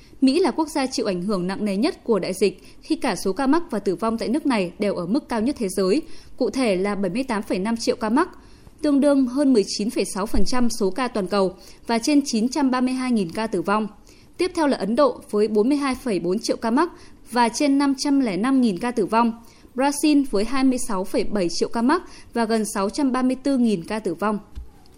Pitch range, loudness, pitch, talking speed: 205-280 Hz, -22 LUFS, 235 Hz, 190 wpm